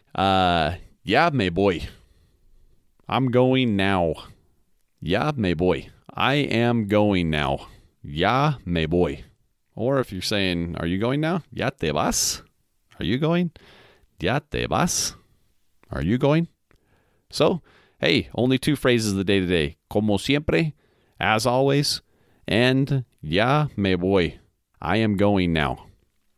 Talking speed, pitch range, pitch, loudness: 135 wpm, 90-130 Hz, 105 Hz, -22 LUFS